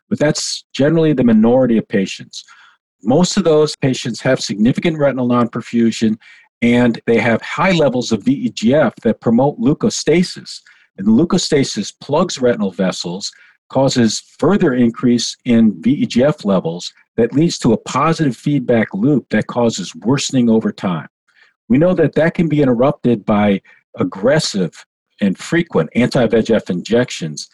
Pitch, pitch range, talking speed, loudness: 135 Hz, 120-180 Hz, 140 wpm, -15 LUFS